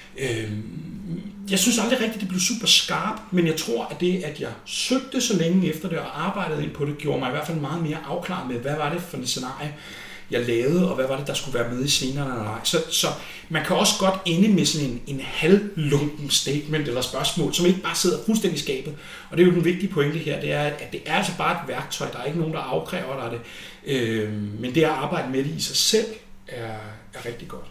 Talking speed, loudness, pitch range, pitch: 245 wpm, -23 LUFS, 135-180 Hz, 155 Hz